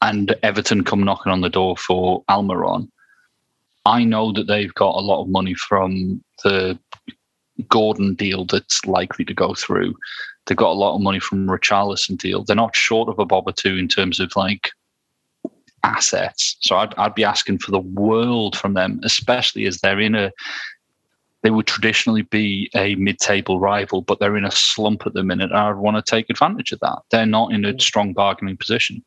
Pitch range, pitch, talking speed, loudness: 95-110 Hz, 100 Hz, 195 wpm, -18 LUFS